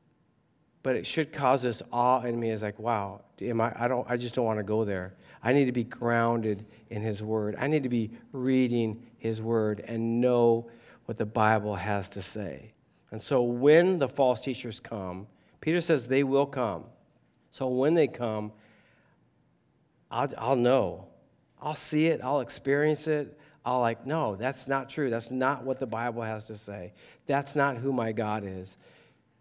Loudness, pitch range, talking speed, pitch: -28 LUFS, 110-135 Hz, 185 wpm, 120 Hz